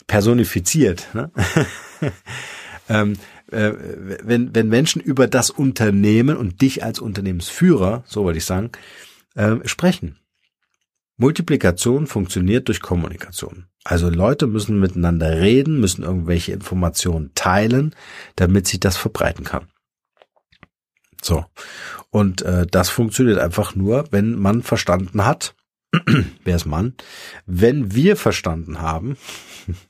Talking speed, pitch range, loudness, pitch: 110 wpm, 90-120 Hz, -18 LUFS, 105 Hz